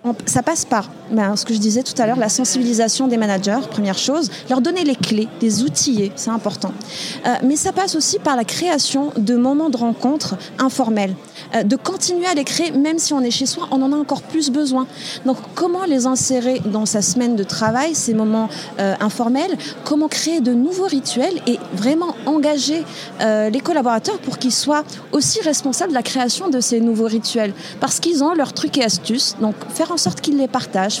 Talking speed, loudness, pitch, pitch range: 205 wpm, -18 LUFS, 255 Hz, 225-295 Hz